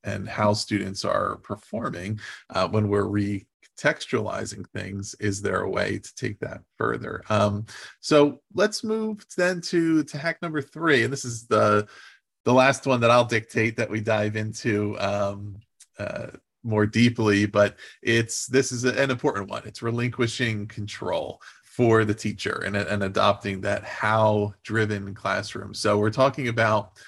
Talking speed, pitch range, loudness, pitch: 155 wpm, 105-125 Hz, -24 LUFS, 110 Hz